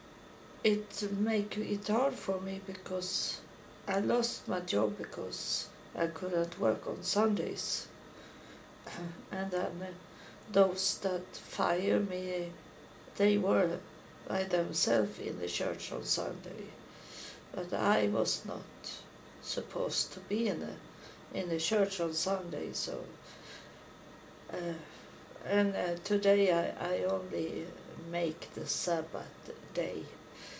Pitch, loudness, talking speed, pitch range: 190 Hz, -31 LUFS, 115 wpm, 175-205 Hz